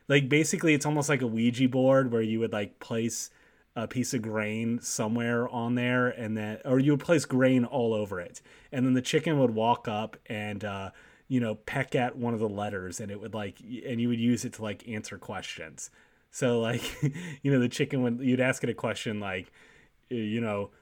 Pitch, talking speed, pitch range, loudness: 120 Hz, 215 wpm, 110-130 Hz, -29 LUFS